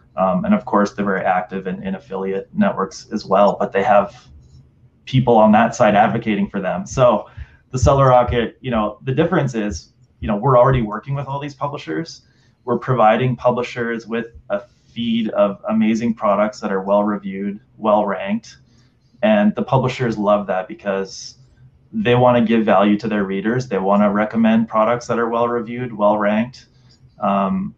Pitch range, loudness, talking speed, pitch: 105-130 Hz, -18 LUFS, 175 wpm, 115 Hz